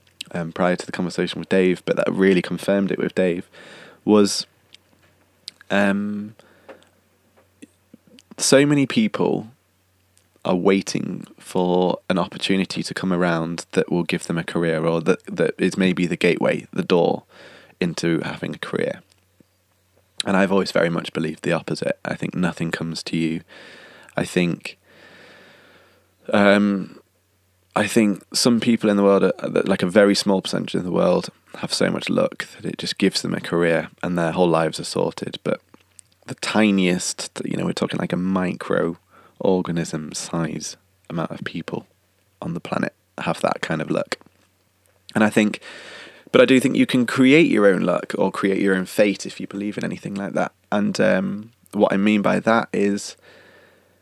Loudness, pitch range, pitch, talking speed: -21 LUFS, 90-100 Hz, 95 Hz, 170 wpm